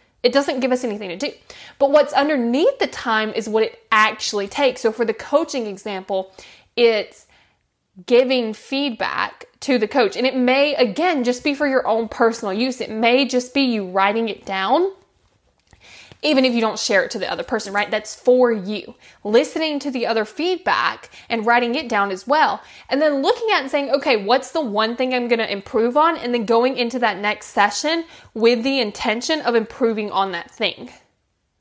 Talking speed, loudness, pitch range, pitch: 195 wpm, -19 LUFS, 220-280 Hz, 240 Hz